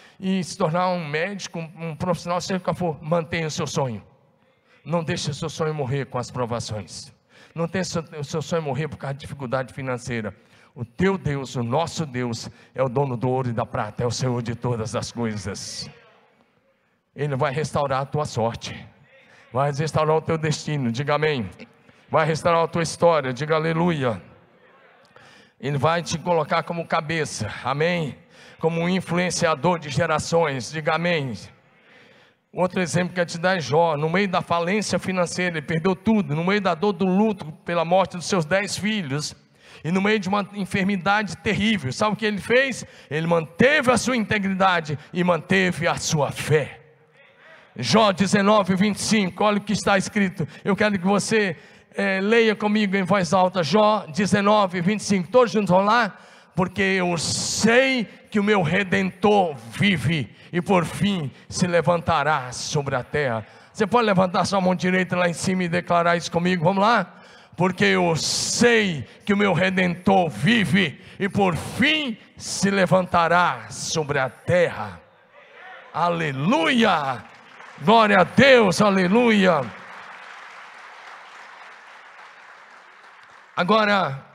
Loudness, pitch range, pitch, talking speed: -22 LUFS, 150-200 Hz, 175 Hz, 155 wpm